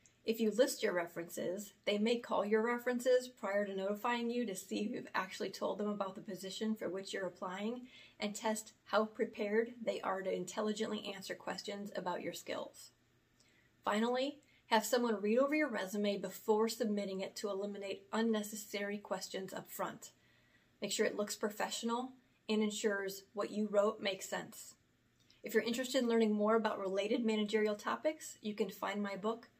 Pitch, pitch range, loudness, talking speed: 215 Hz, 200-230 Hz, -38 LUFS, 170 wpm